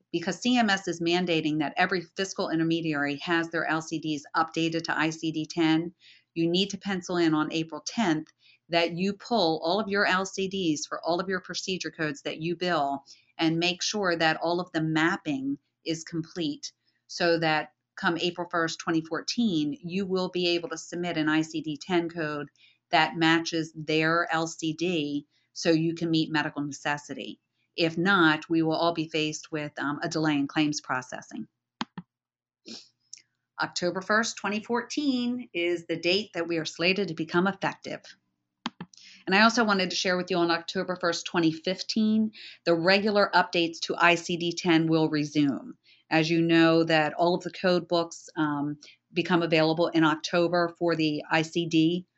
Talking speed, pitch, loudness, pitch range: 160 wpm, 170 Hz, -27 LUFS, 160-180 Hz